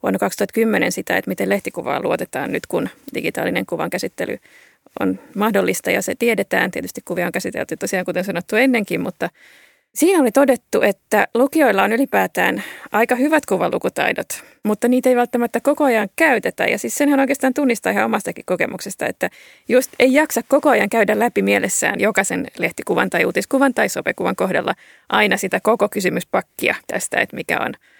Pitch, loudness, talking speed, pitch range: 240 Hz, -18 LUFS, 160 wpm, 210-275 Hz